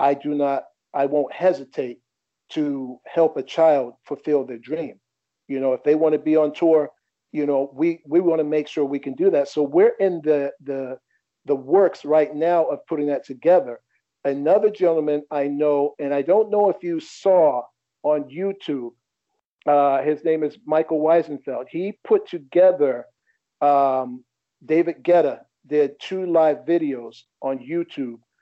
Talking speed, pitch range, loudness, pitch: 165 wpm, 140-165 Hz, -21 LUFS, 150 Hz